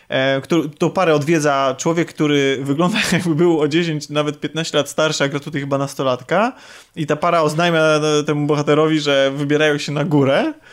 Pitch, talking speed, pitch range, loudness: 150 Hz, 170 wpm, 145-165 Hz, -17 LUFS